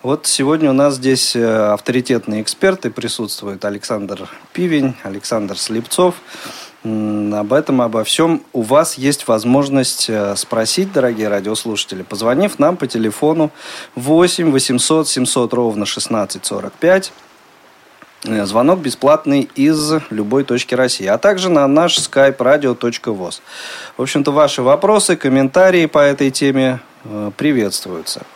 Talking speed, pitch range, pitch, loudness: 110 wpm, 110-155 Hz, 130 Hz, -15 LUFS